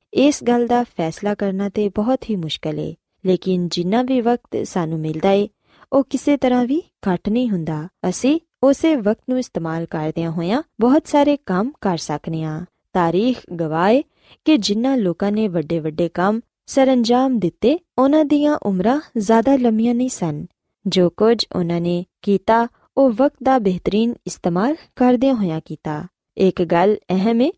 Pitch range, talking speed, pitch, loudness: 175-255 Hz, 155 wpm, 210 Hz, -19 LUFS